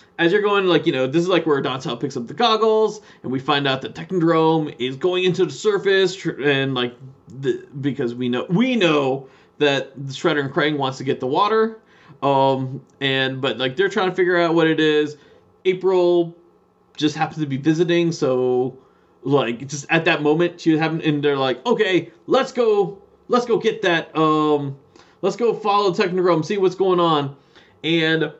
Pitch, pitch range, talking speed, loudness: 160 Hz, 140-185 Hz, 190 wpm, -20 LUFS